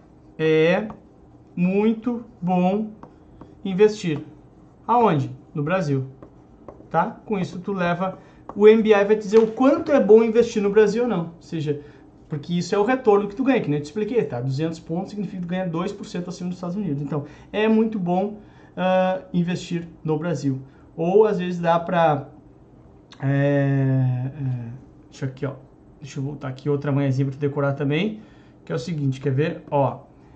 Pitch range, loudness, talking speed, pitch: 145-205 Hz, -22 LUFS, 165 wpm, 170 Hz